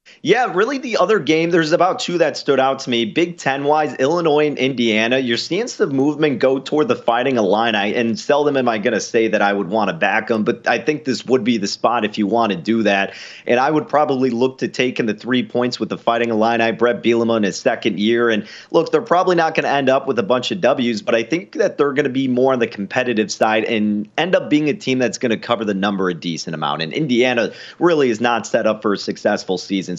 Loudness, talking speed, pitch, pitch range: -18 LUFS, 260 wpm, 120 Hz, 110-145 Hz